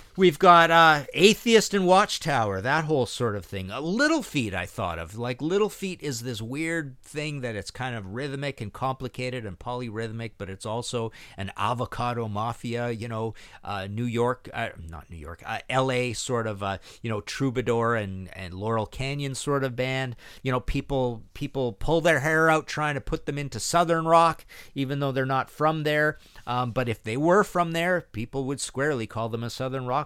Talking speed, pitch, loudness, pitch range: 200 wpm, 125 Hz, -26 LUFS, 115-150 Hz